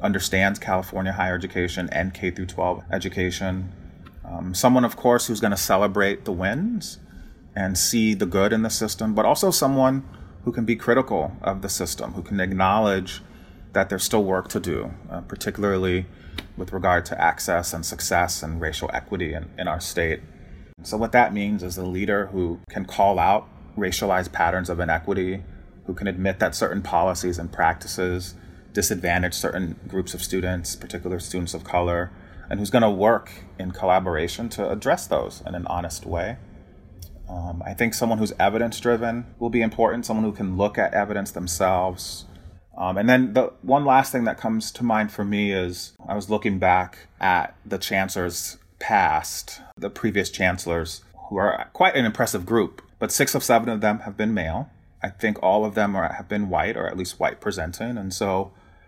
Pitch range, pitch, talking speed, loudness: 90-110 Hz, 95 Hz, 180 wpm, -23 LUFS